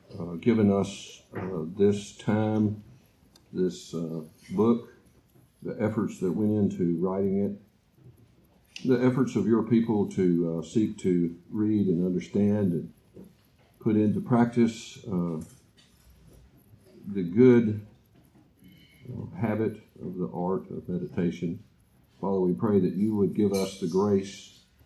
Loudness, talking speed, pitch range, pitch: -27 LUFS, 125 wpm, 95-115 Hz, 105 Hz